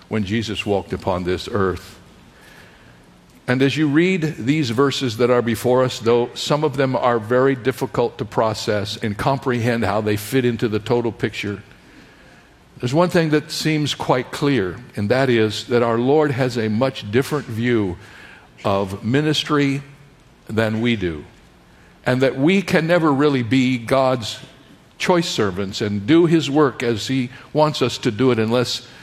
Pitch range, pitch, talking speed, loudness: 110-140 Hz, 125 Hz, 165 wpm, -19 LUFS